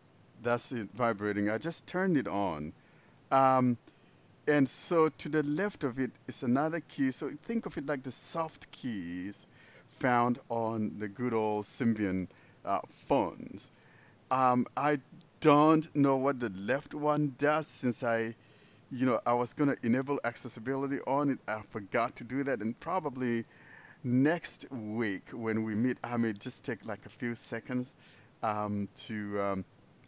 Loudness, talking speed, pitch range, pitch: -30 LUFS, 160 wpm, 115-145 Hz, 125 Hz